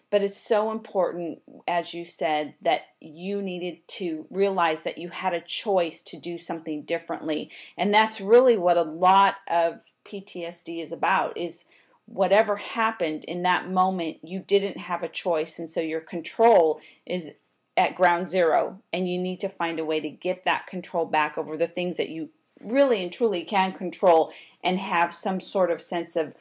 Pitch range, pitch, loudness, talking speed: 165-195 Hz, 175 Hz, -25 LUFS, 180 wpm